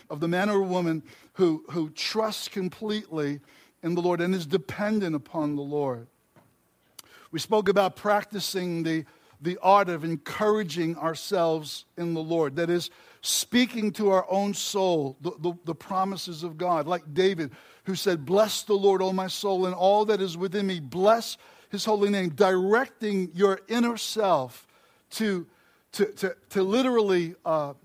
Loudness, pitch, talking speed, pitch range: -26 LUFS, 185 Hz, 160 wpm, 165-200 Hz